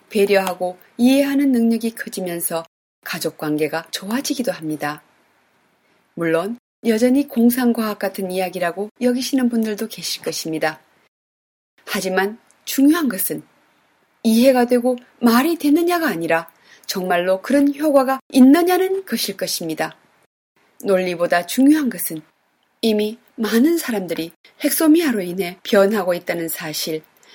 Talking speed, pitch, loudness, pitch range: 285 characters per minute, 210 Hz, -19 LUFS, 175-255 Hz